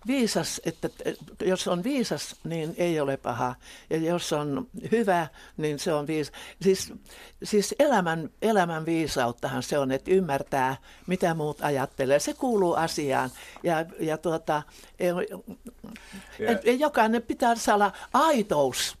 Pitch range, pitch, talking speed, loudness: 150-215 Hz, 175 Hz, 135 wpm, -27 LUFS